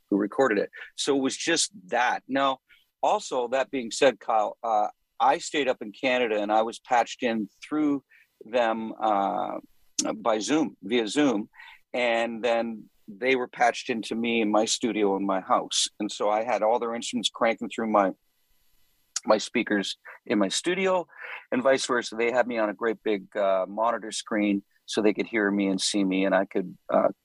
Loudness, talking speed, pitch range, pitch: -26 LUFS, 185 wpm, 105-125 Hz, 115 Hz